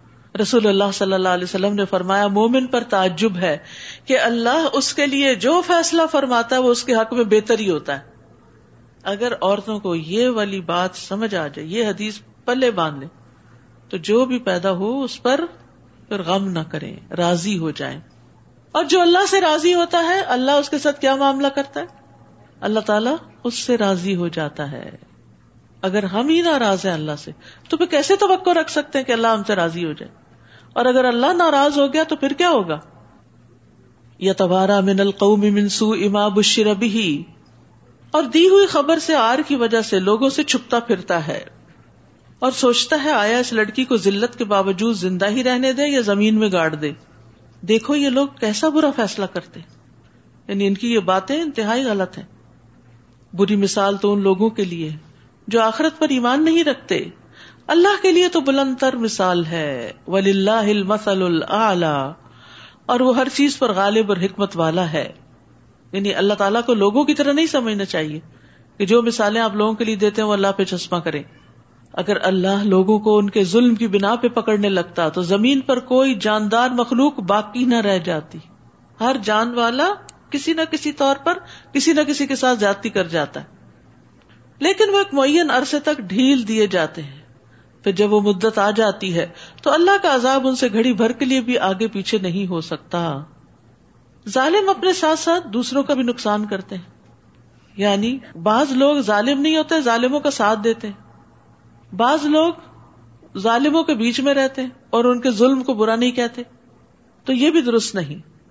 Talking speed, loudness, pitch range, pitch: 185 wpm, -18 LUFS, 190-270 Hz, 220 Hz